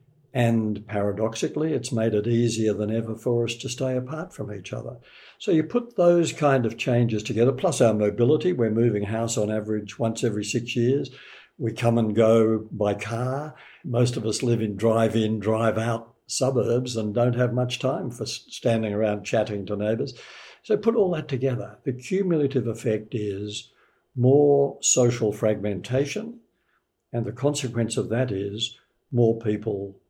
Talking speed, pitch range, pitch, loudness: 165 wpm, 110-130 Hz, 115 Hz, -24 LUFS